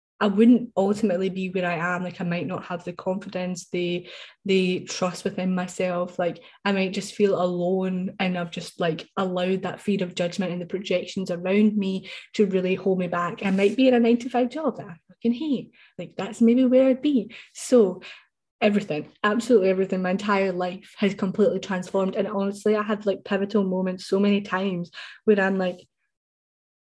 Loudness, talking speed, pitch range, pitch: -24 LUFS, 190 wpm, 180-210 Hz, 190 Hz